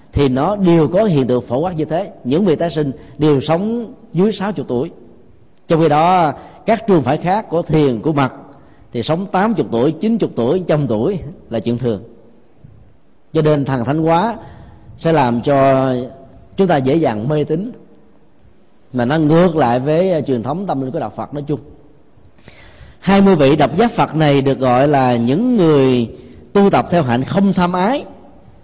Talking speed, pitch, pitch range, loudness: 185 wpm, 150 Hz, 125-175 Hz, -15 LUFS